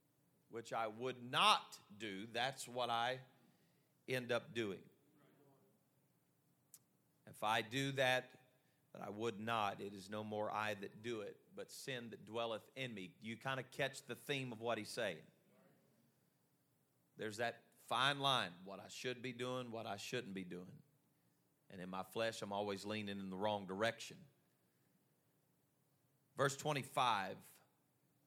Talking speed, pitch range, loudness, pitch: 150 wpm, 105-135 Hz, -42 LUFS, 120 Hz